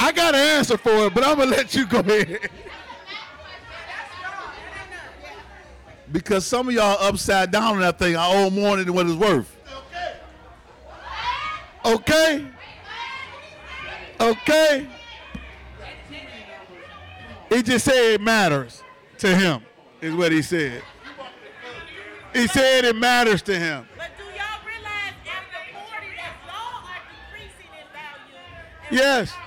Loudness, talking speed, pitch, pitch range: -20 LUFS, 100 wpm, 235 Hz, 190-305 Hz